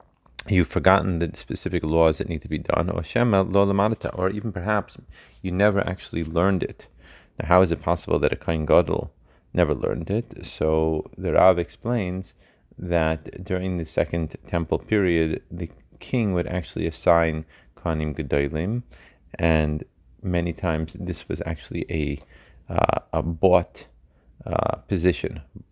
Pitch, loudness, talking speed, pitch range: 85 Hz, -24 LUFS, 140 wpm, 80-95 Hz